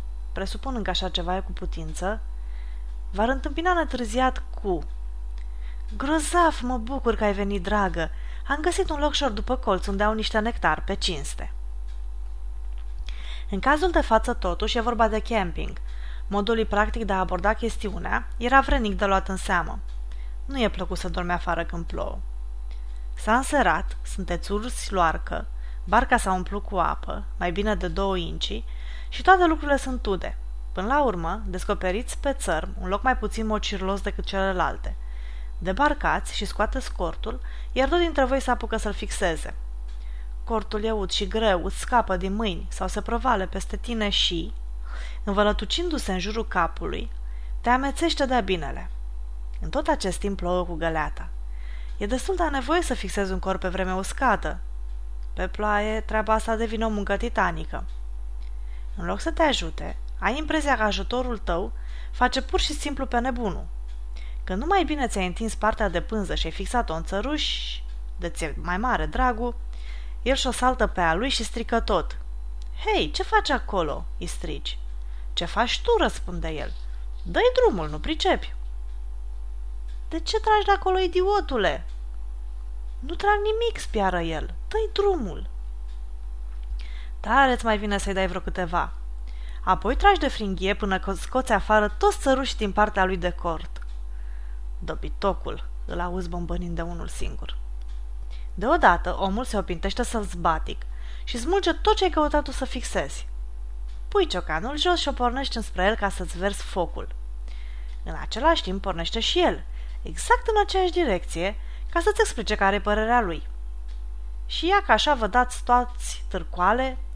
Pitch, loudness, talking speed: 195 Hz, -25 LUFS, 155 wpm